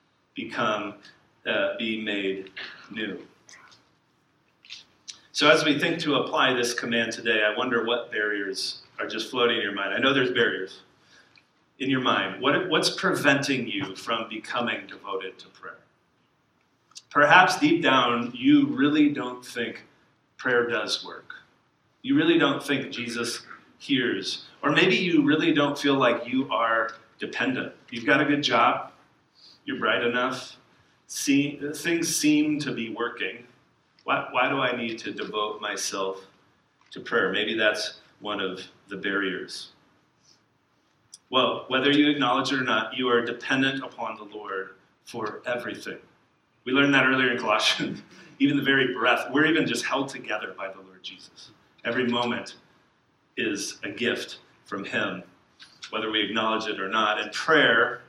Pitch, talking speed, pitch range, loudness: 125 Hz, 150 wpm, 110-145 Hz, -24 LUFS